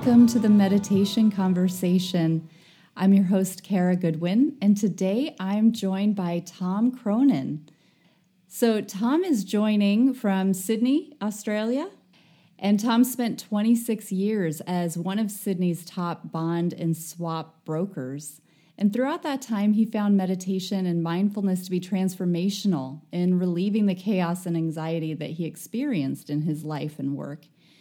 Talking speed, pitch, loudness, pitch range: 140 wpm, 190 Hz, -25 LUFS, 170-210 Hz